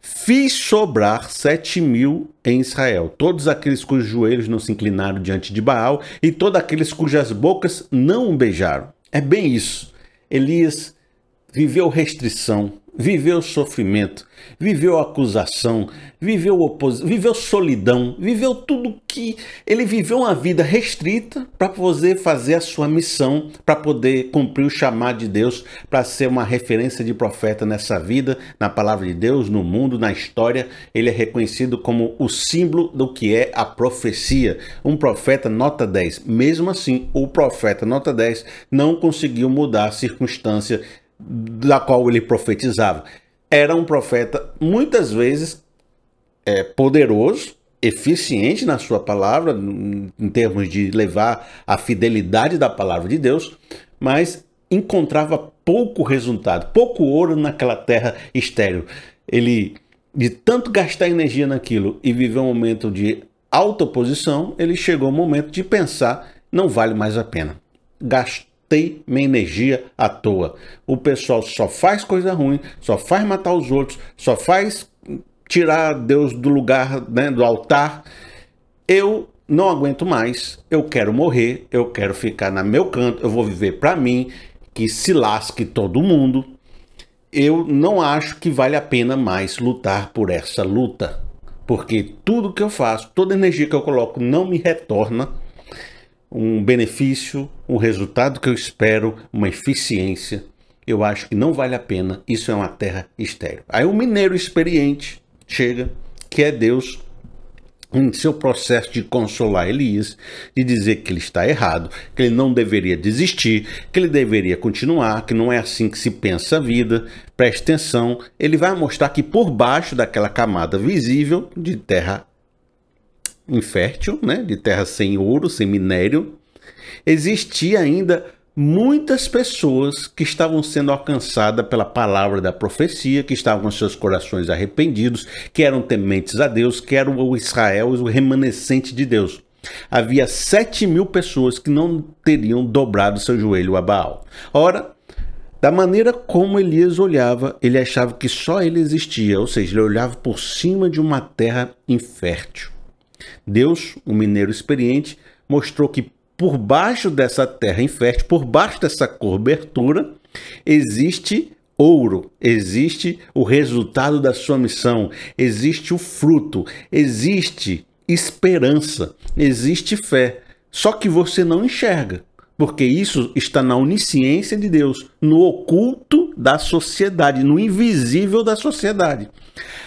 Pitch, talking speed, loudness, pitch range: 130 Hz, 145 wpm, -18 LUFS, 115-160 Hz